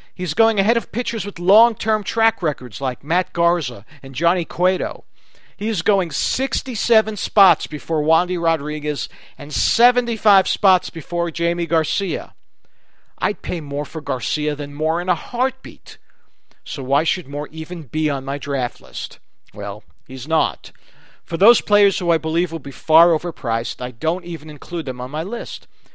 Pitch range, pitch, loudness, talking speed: 150-195 Hz, 170 Hz, -20 LUFS, 165 wpm